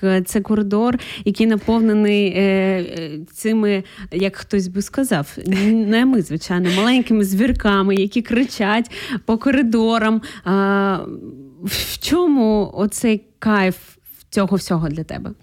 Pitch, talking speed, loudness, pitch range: 205 Hz, 110 wpm, -18 LUFS, 190-225 Hz